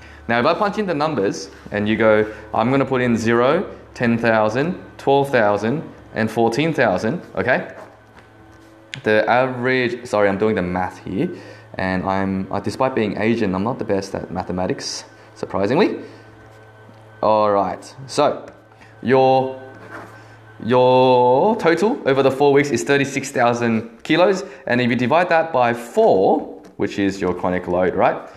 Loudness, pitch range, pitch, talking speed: -19 LUFS, 105-130 Hz, 110 Hz, 140 wpm